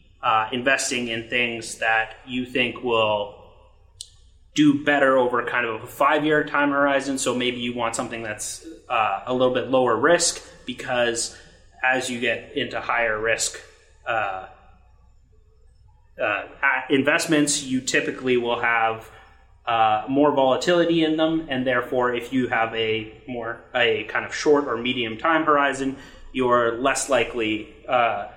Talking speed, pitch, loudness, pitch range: 140 wpm, 120 Hz, -22 LUFS, 110-135 Hz